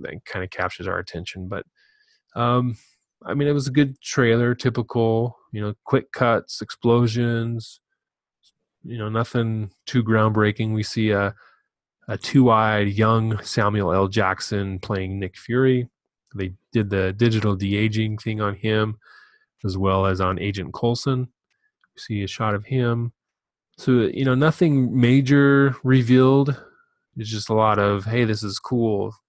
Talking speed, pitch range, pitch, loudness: 150 wpm, 105-125 Hz, 115 Hz, -21 LUFS